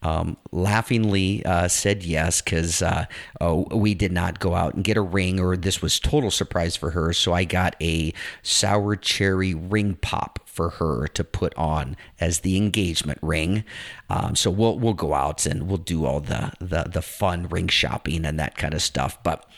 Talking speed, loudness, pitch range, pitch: 195 wpm, -23 LUFS, 80-100 Hz, 90 Hz